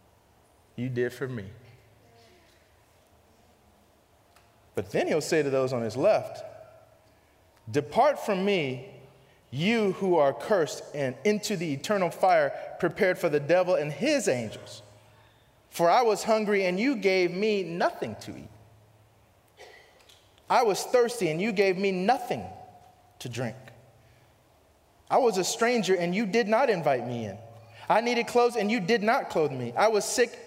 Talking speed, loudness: 150 wpm, -26 LUFS